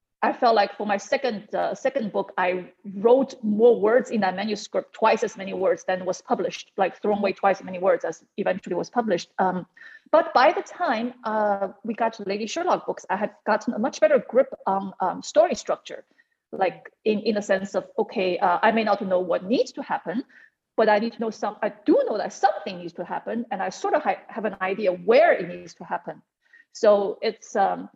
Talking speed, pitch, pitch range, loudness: 220 wpm, 215 Hz, 195-250 Hz, -24 LUFS